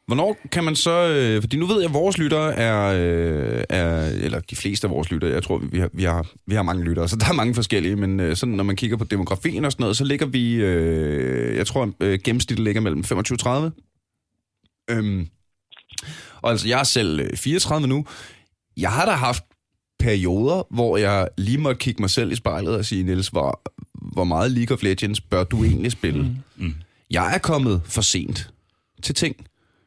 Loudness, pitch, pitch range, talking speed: -22 LUFS, 110 Hz, 95-125 Hz, 195 wpm